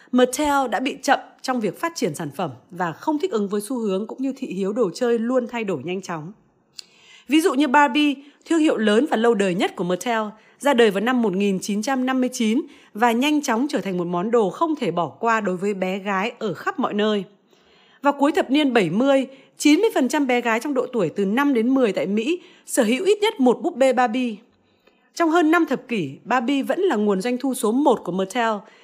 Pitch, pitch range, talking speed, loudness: 245 Hz, 205-280 Hz, 220 wpm, -21 LUFS